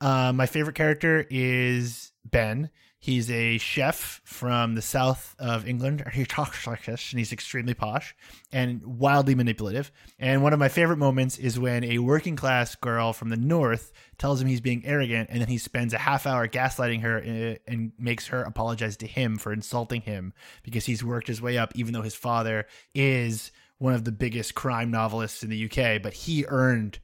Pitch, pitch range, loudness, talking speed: 120 Hz, 115-130 Hz, -26 LUFS, 190 wpm